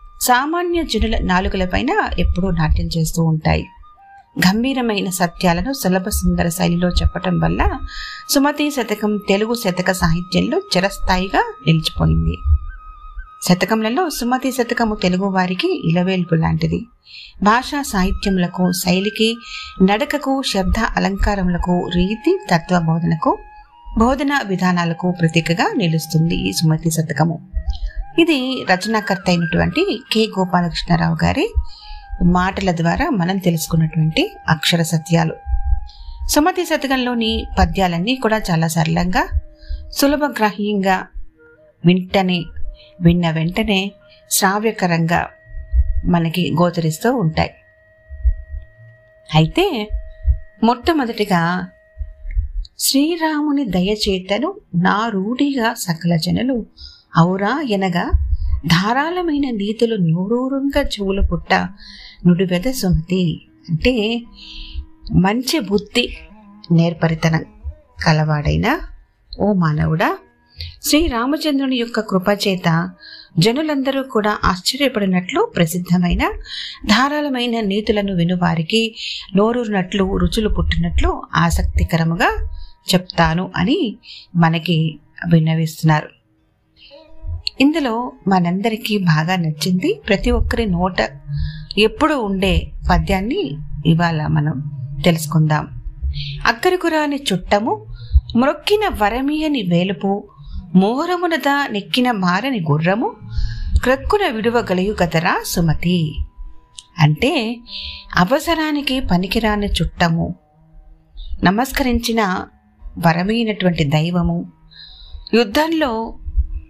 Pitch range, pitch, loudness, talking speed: 160-235 Hz, 185 Hz, -18 LUFS, 75 wpm